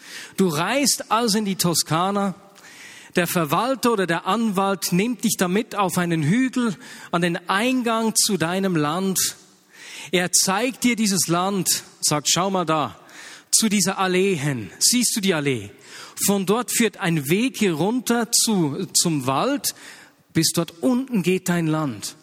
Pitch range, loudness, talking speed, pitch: 170-220 Hz, -21 LUFS, 150 wpm, 190 Hz